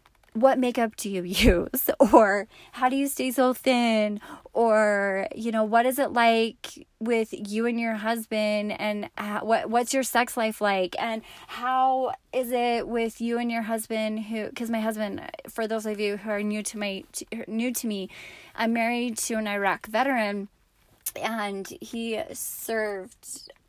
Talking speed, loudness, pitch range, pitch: 165 wpm, -26 LUFS, 210-240 Hz, 225 Hz